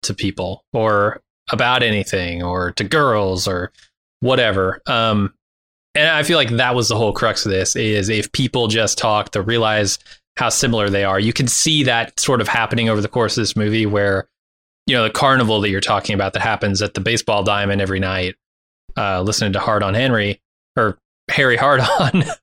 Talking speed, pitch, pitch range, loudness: 195 wpm, 105 Hz, 95-115 Hz, -17 LUFS